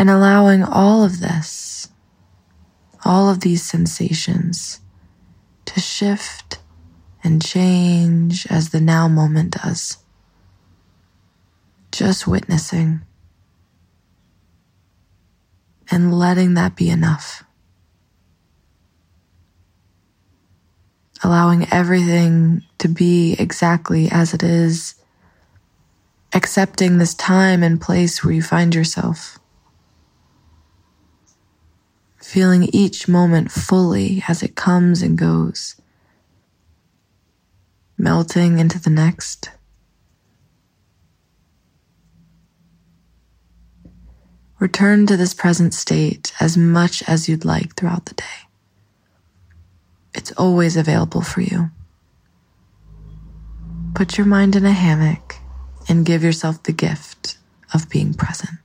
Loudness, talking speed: -16 LUFS, 90 wpm